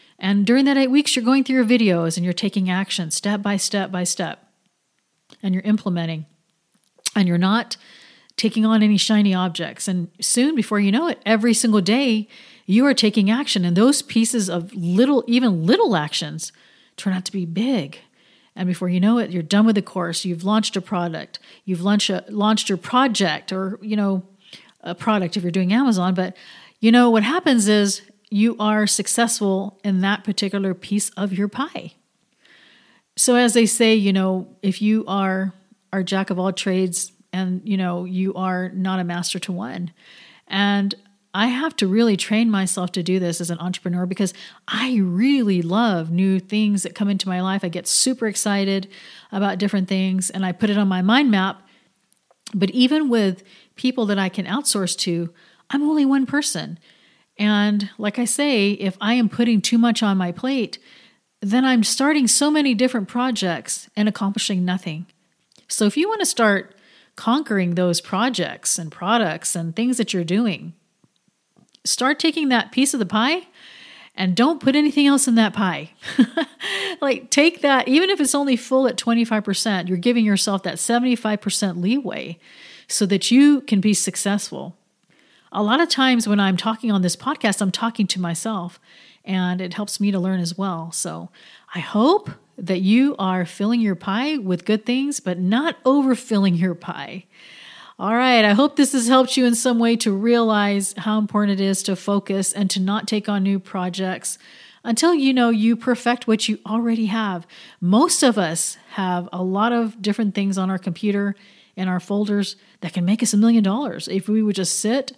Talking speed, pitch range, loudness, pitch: 185 wpm, 190-235 Hz, -20 LUFS, 205 Hz